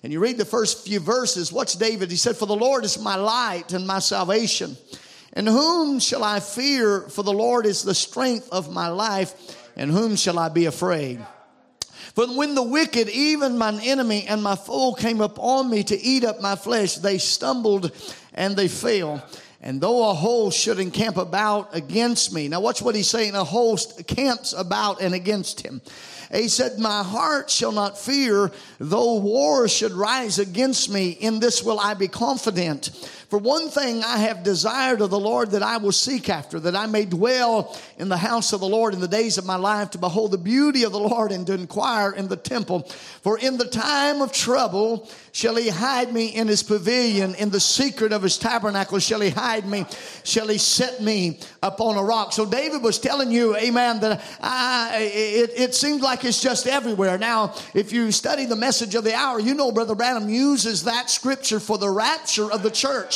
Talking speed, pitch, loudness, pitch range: 200 wpm, 220 Hz, -21 LUFS, 200-240 Hz